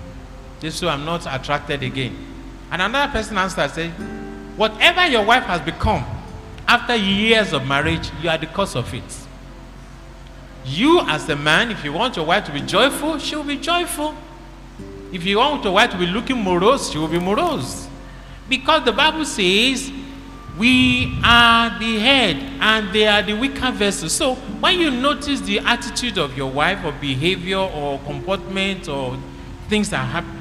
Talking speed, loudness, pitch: 170 wpm, -18 LUFS, 200 Hz